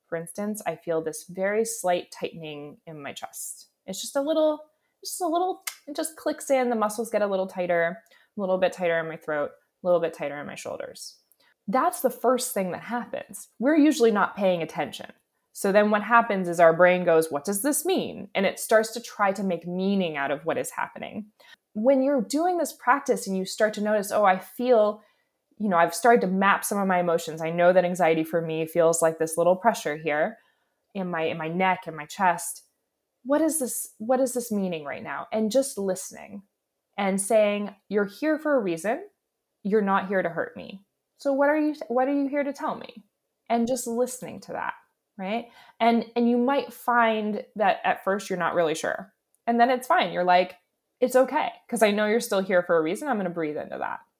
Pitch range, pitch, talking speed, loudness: 175-250 Hz, 210 Hz, 220 wpm, -25 LUFS